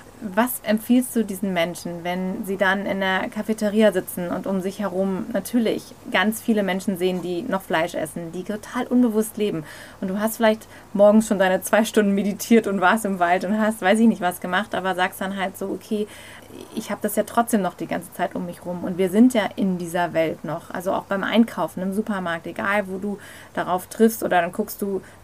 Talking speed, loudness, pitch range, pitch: 215 wpm, -22 LUFS, 185-215 Hz, 200 Hz